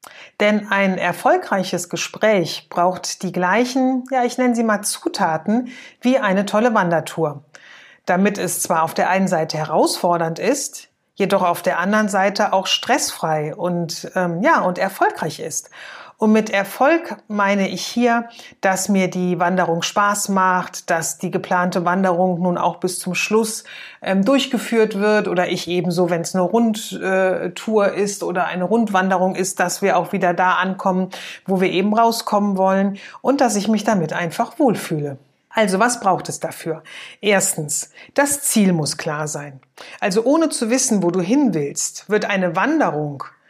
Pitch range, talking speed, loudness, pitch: 180-220 Hz, 160 wpm, -19 LUFS, 190 Hz